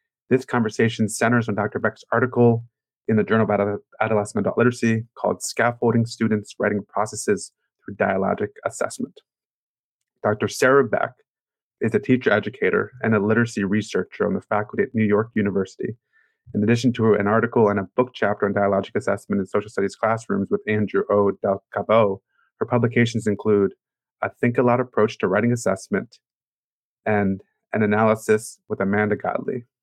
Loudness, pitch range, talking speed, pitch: -22 LUFS, 105-120 Hz, 155 wpm, 110 Hz